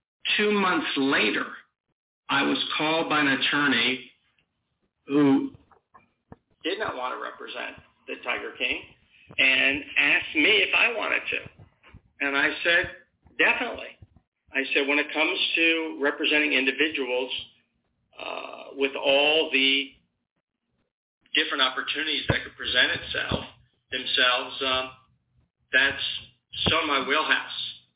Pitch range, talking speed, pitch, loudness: 130-150 Hz, 115 wpm, 140 Hz, -23 LUFS